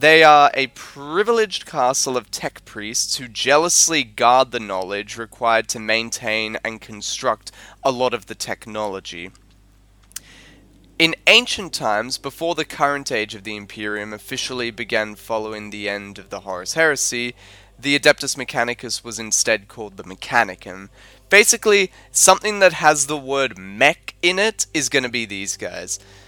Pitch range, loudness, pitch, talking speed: 105-145 Hz, -18 LUFS, 120 Hz, 150 wpm